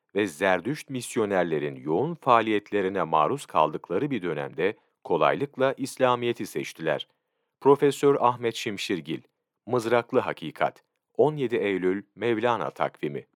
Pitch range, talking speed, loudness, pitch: 110-130 Hz, 95 wpm, -26 LUFS, 120 Hz